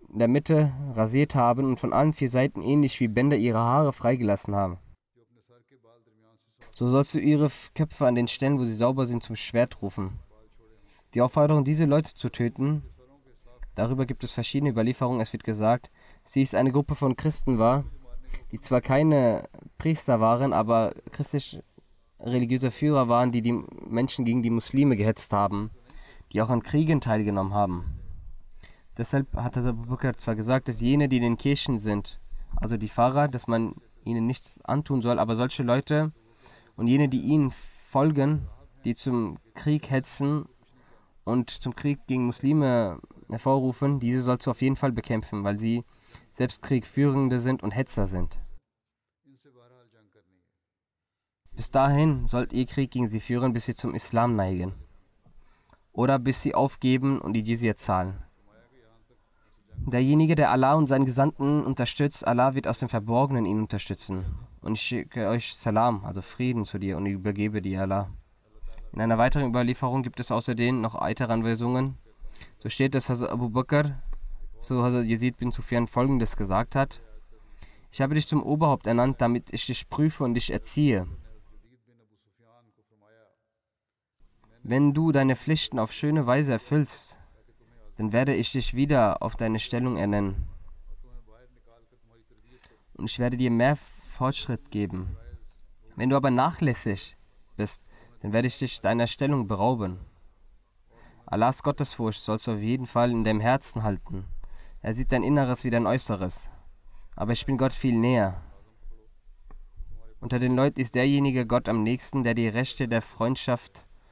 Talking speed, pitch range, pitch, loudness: 150 wpm, 110-130 Hz, 120 Hz, -26 LUFS